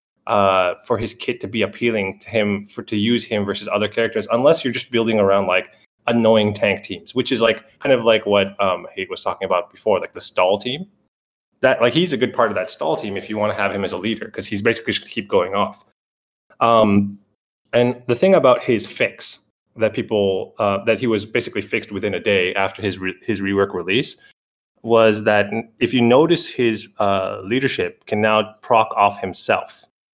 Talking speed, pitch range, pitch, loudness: 210 wpm, 100-120 Hz, 110 Hz, -19 LUFS